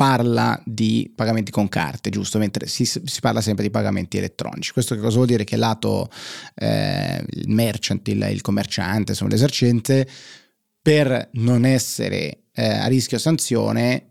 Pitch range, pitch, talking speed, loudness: 110-130 Hz, 115 Hz, 155 wpm, -21 LUFS